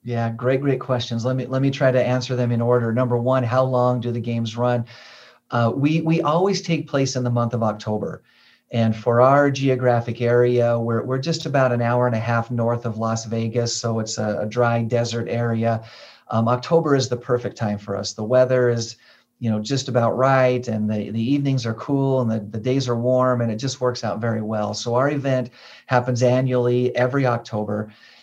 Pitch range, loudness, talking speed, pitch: 115-130 Hz, -21 LUFS, 215 wpm, 120 Hz